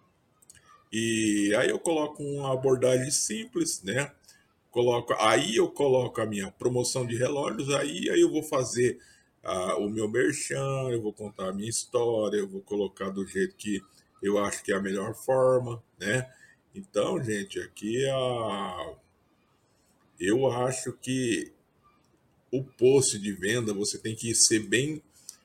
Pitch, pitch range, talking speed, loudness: 125 Hz, 105-135 Hz, 150 wpm, -28 LUFS